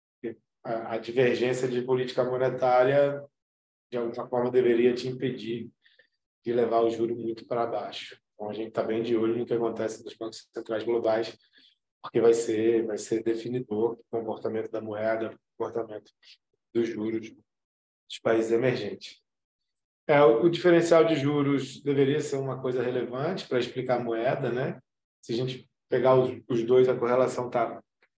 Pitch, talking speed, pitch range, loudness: 120 Hz, 155 wpm, 115-130 Hz, -27 LUFS